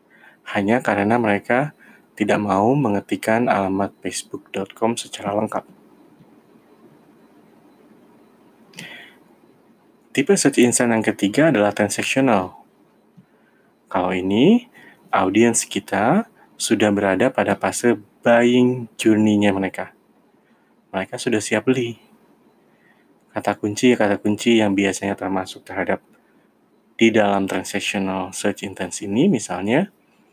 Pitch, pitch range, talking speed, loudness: 105 Hz, 100-120 Hz, 90 wpm, -20 LUFS